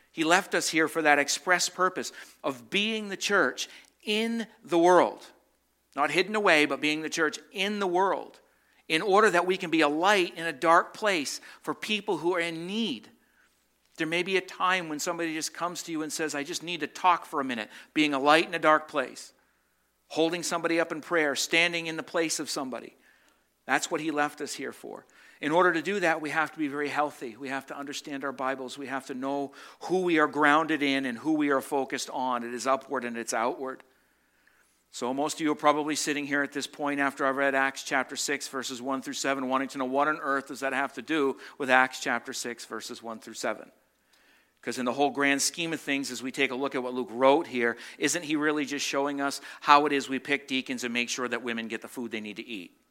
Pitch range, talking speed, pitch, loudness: 135-165 Hz, 235 wpm, 145 Hz, -27 LUFS